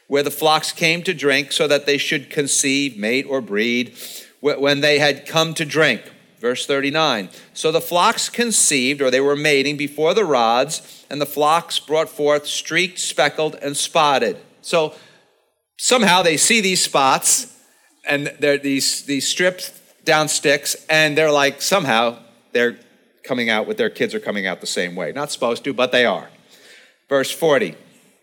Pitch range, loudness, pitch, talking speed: 140-160 Hz, -18 LUFS, 145 Hz, 170 wpm